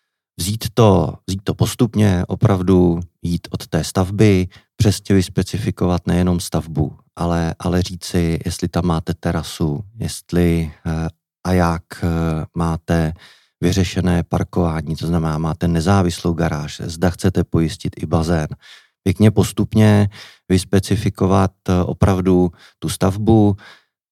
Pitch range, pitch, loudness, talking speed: 85-95 Hz, 90 Hz, -18 LUFS, 110 wpm